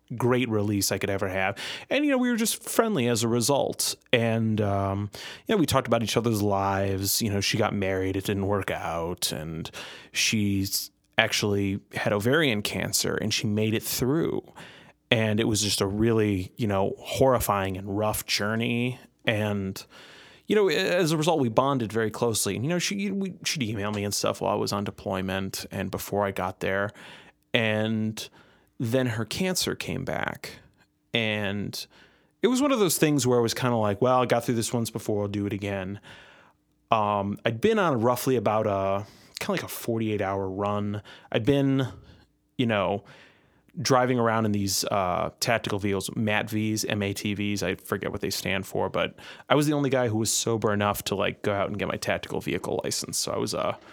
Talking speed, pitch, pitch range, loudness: 195 wpm, 110 Hz, 100-125 Hz, -26 LUFS